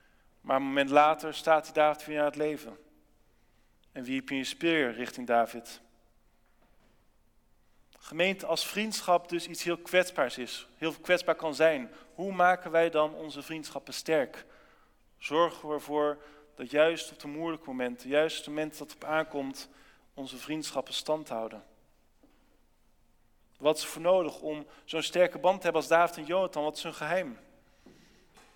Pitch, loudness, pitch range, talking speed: 155 Hz, -30 LUFS, 140-170 Hz, 165 wpm